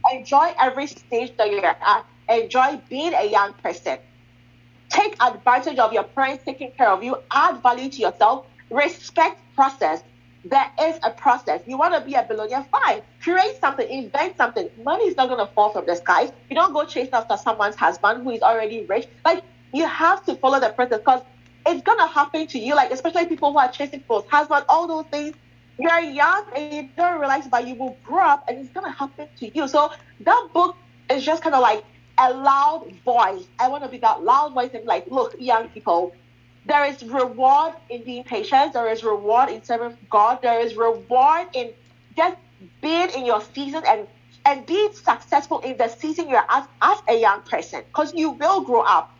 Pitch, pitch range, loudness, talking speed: 270 Hz, 230-315 Hz, -20 LUFS, 205 wpm